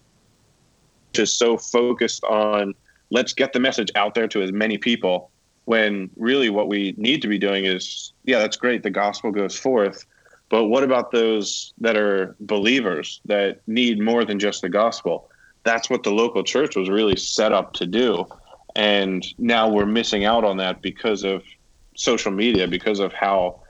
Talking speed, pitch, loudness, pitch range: 175 wpm, 105 Hz, -21 LUFS, 100-115 Hz